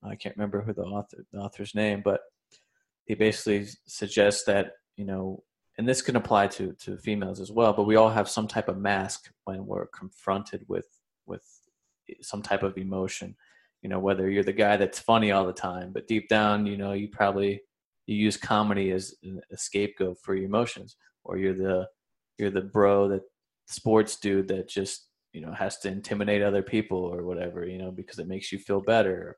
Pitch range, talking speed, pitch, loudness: 95-105 Hz, 200 wpm, 100 Hz, -27 LUFS